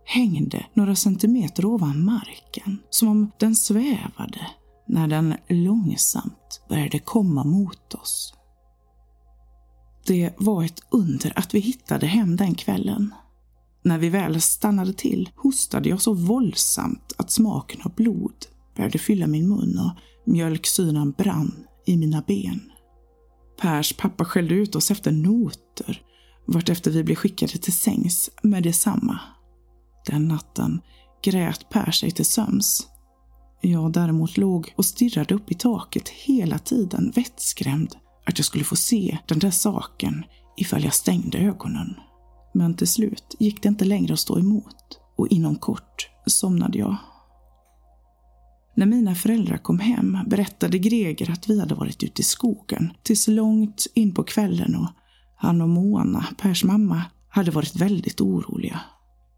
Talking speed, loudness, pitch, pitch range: 140 wpm, -22 LUFS, 190 Hz, 155-215 Hz